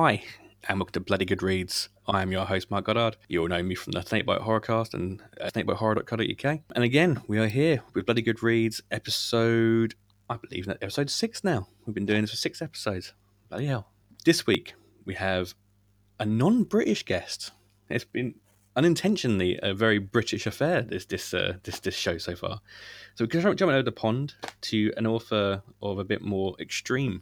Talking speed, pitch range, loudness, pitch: 190 wpm, 100-120 Hz, -27 LUFS, 110 Hz